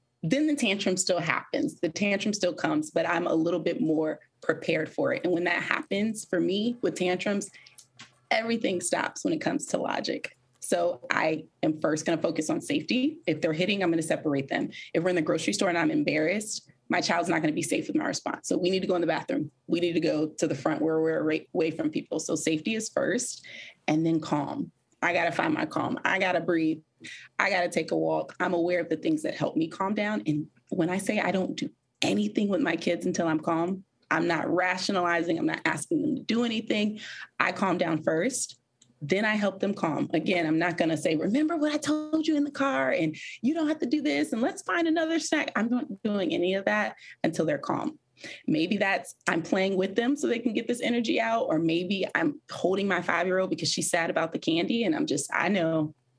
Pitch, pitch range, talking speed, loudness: 185 Hz, 165-255 Hz, 235 wpm, -28 LUFS